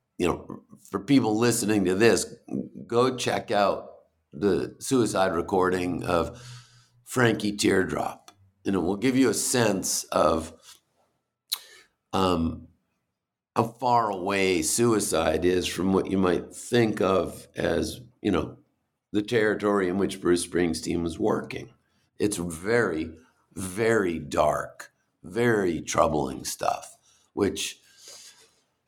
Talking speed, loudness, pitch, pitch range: 115 wpm, -26 LUFS, 100 Hz, 90-115 Hz